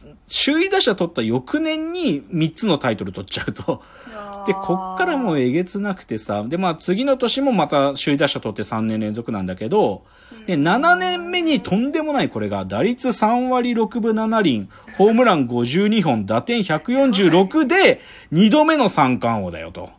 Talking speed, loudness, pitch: 290 characters per minute, -19 LUFS, 200 Hz